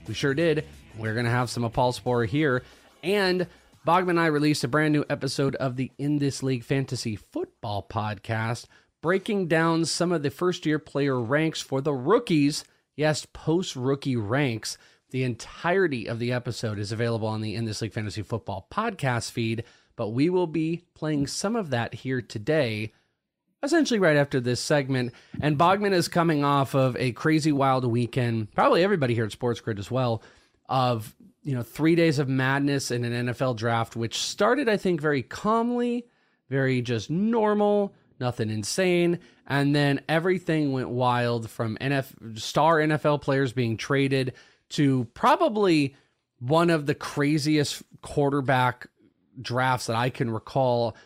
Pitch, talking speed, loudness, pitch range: 135 Hz, 165 wpm, -25 LUFS, 120-155 Hz